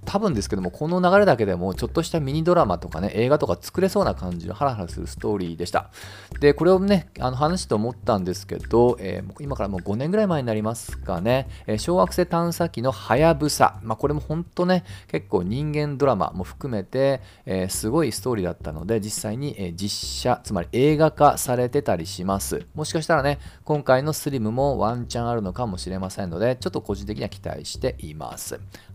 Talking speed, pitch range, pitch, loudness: 425 characters per minute, 100-150 Hz, 120 Hz, -23 LUFS